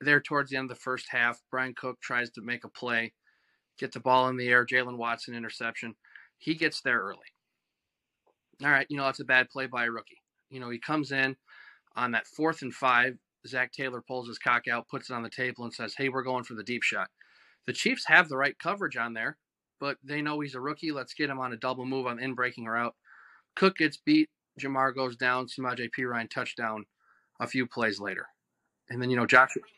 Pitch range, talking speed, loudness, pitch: 120-135 Hz, 230 wpm, -29 LUFS, 125 Hz